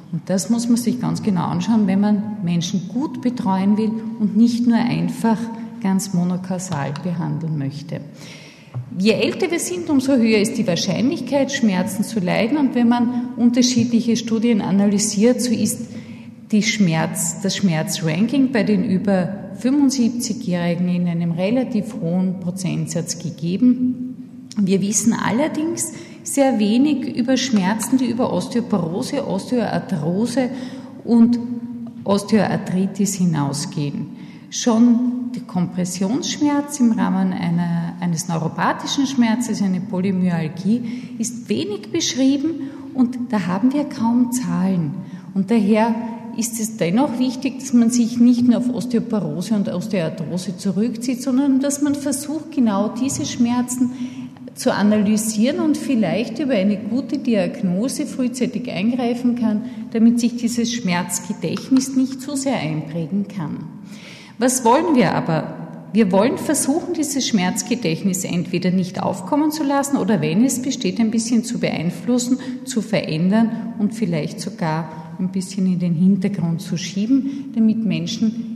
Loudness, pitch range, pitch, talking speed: -19 LUFS, 190-245 Hz, 225 Hz, 130 wpm